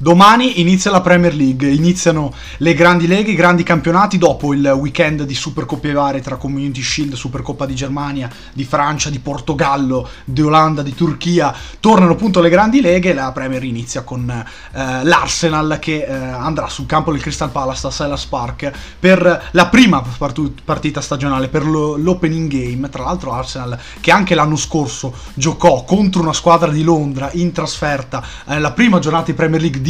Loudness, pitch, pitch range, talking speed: -14 LUFS, 150 Hz, 135-170 Hz, 170 wpm